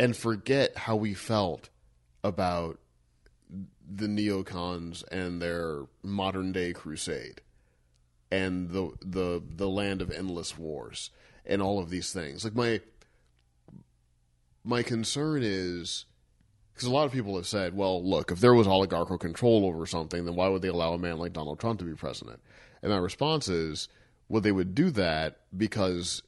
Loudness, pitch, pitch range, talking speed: -30 LUFS, 95 Hz, 85-105 Hz, 160 wpm